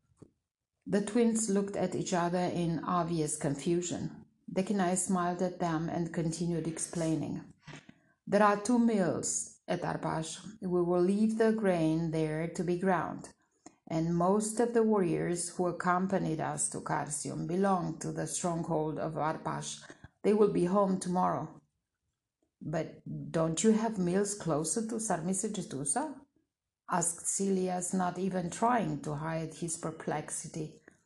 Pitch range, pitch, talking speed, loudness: 165-200 Hz, 180 Hz, 135 wpm, -32 LUFS